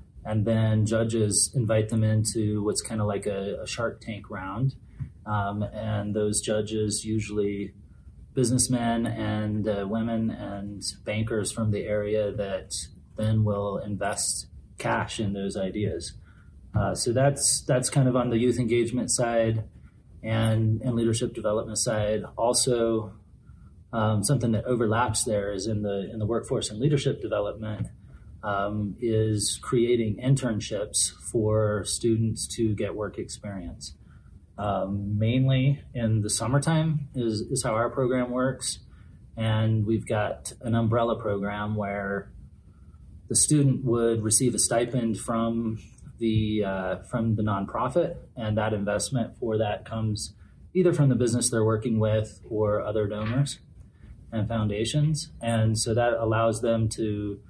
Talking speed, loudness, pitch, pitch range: 140 wpm, -26 LUFS, 110 Hz, 105-115 Hz